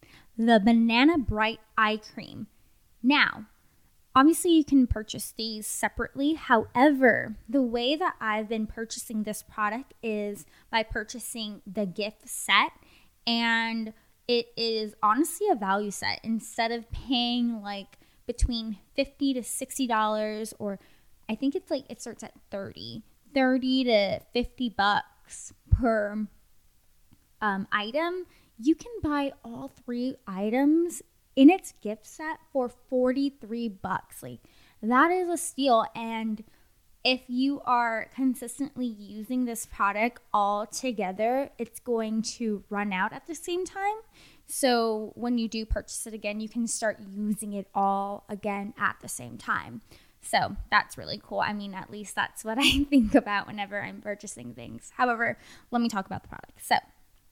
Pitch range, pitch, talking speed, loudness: 210-260 Hz, 230 Hz, 145 wpm, -27 LUFS